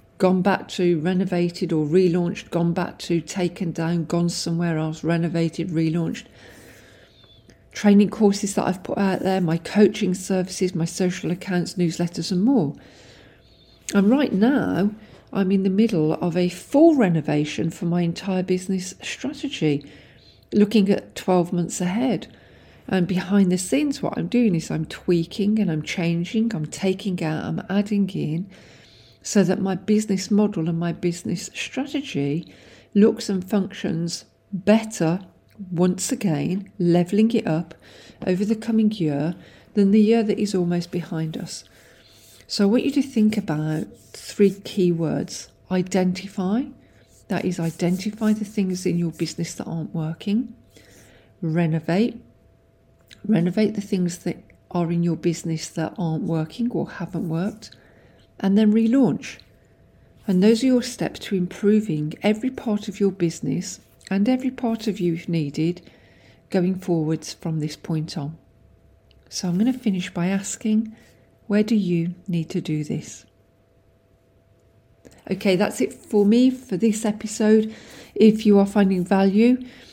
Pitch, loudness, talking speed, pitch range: 185 Hz, -22 LUFS, 145 wpm, 165-210 Hz